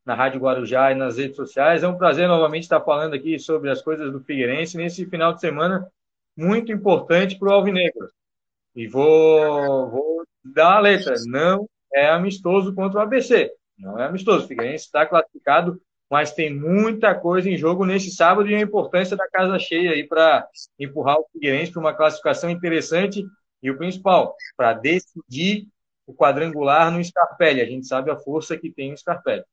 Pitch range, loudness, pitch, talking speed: 145-190 Hz, -20 LUFS, 165 Hz, 175 wpm